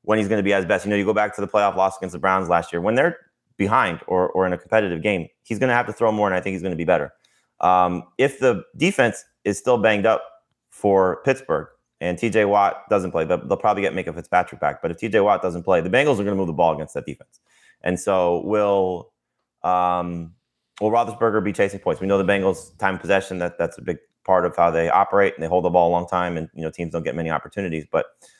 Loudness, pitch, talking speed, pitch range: -21 LUFS, 95 Hz, 265 wpm, 90-105 Hz